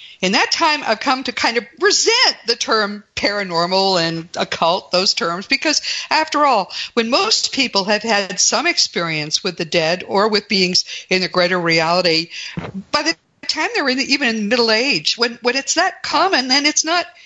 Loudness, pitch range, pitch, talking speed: -16 LUFS, 185-295 Hz, 230 Hz, 185 wpm